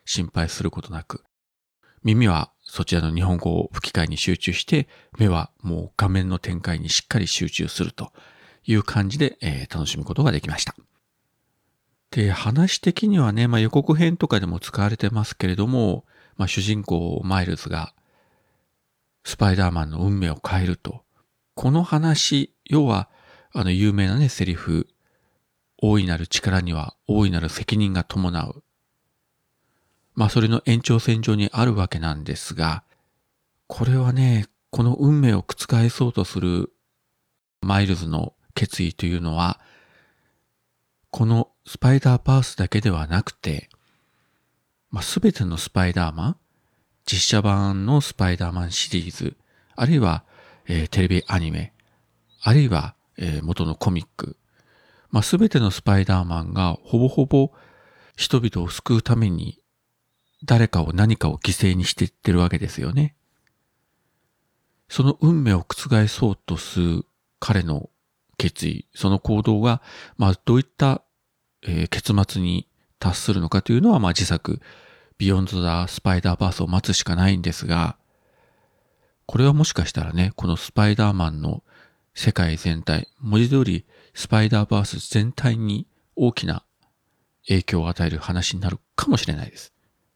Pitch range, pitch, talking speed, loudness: 90-115 Hz, 100 Hz, 285 characters per minute, -22 LUFS